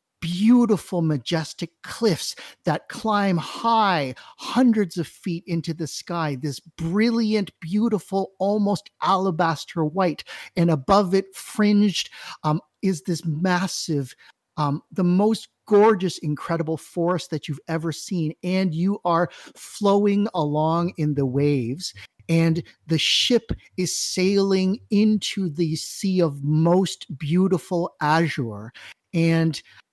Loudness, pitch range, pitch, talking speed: -23 LUFS, 160-195 Hz, 175 Hz, 115 wpm